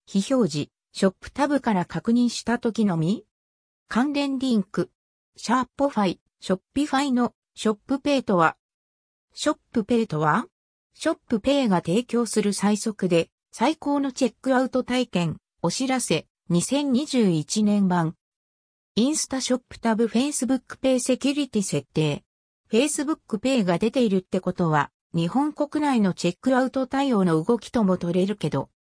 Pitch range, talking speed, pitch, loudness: 180-260 Hz, 330 characters per minute, 230 Hz, -24 LUFS